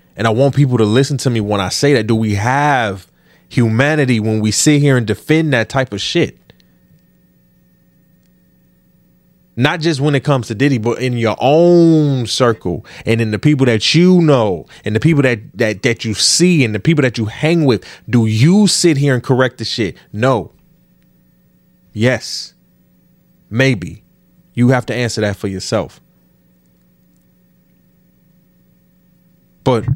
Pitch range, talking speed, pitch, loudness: 105-140 Hz, 160 wpm, 120 Hz, -14 LUFS